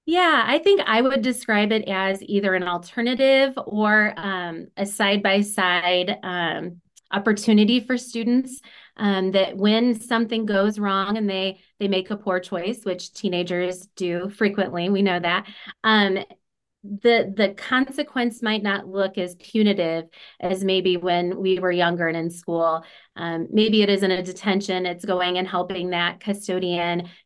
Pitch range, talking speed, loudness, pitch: 180-215 Hz, 155 wpm, -22 LUFS, 195 Hz